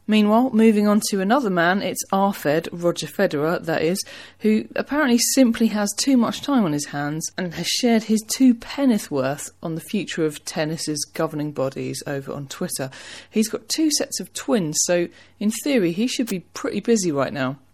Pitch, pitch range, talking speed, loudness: 195 Hz, 155-230 Hz, 185 wpm, -21 LUFS